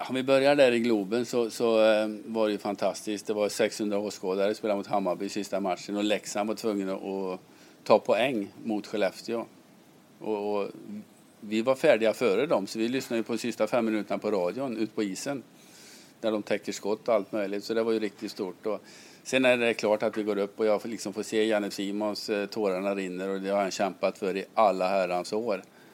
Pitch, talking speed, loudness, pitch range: 105 Hz, 220 wpm, -28 LUFS, 100-110 Hz